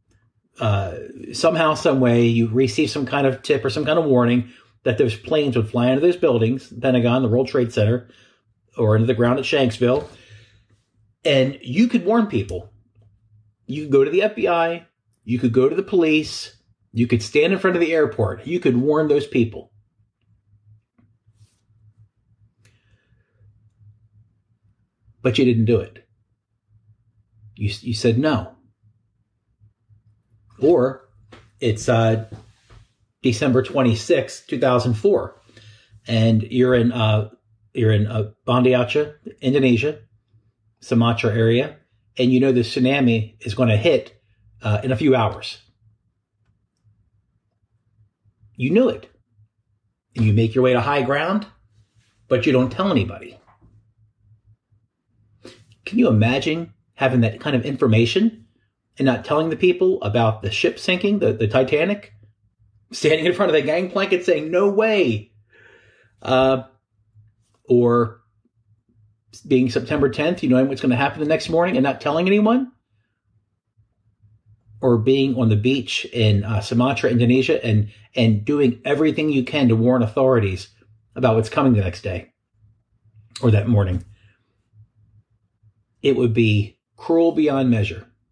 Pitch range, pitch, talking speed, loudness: 110-130 Hz, 115 Hz, 135 wpm, -19 LUFS